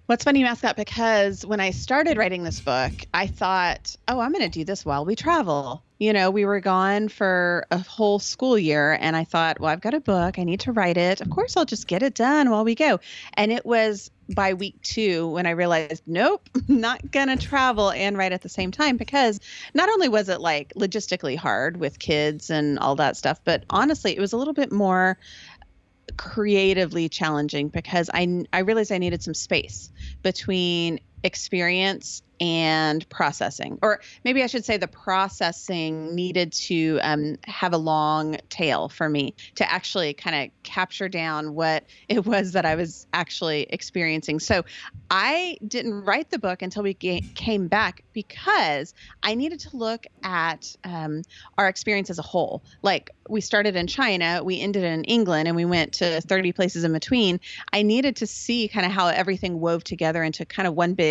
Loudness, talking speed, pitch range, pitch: -23 LUFS, 195 wpm, 165-220 Hz, 190 Hz